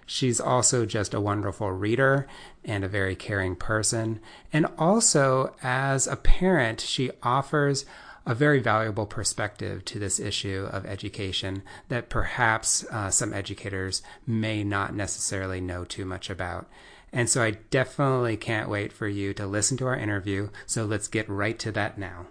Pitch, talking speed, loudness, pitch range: 110 Hz, 160 wpm, -26 LUFS, 100-125 Hz